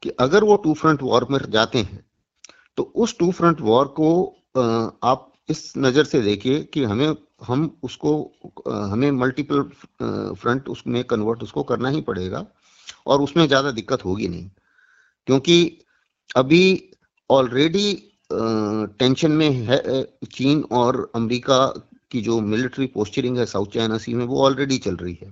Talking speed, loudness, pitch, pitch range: 150 wpm, -20 LUFS, 130 Hz, 115-150 Hz